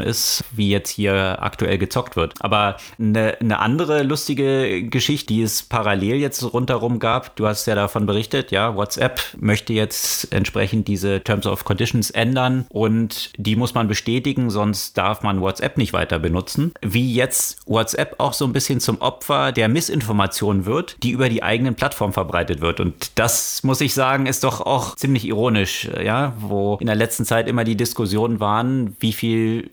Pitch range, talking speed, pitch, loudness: 105-125 Hz, 175 wpm, 115 Hz, -20 LUFS